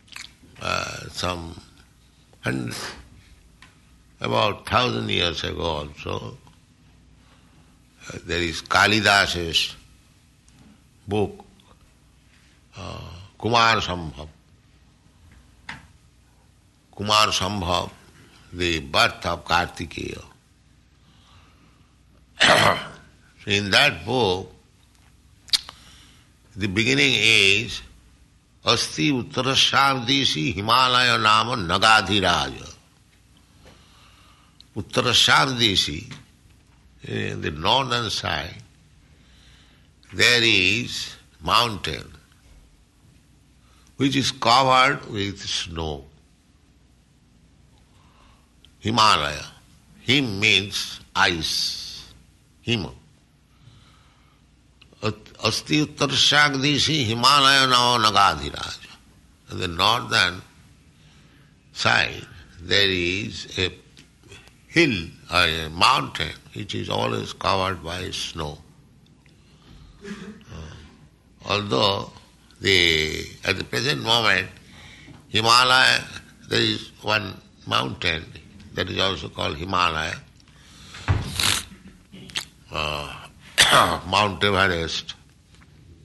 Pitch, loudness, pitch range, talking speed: 95 Hz, -20 LUFS, 80-115 Hz, 60 wpm